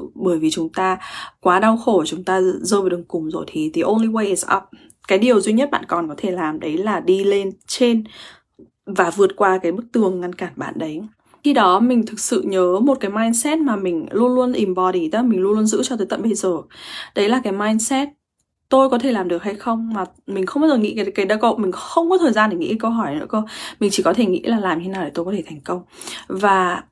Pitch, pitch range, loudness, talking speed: 205 Hz, 185-235 Hz, -19 LUFS, 260 wpm